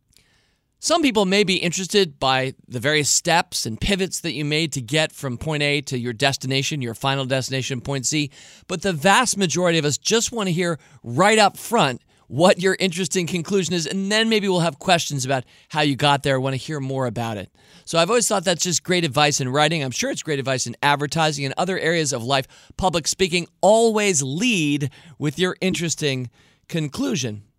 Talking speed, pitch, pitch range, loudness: 200 wpm, 155 Hz, 135-185 Hz, -20 LUFS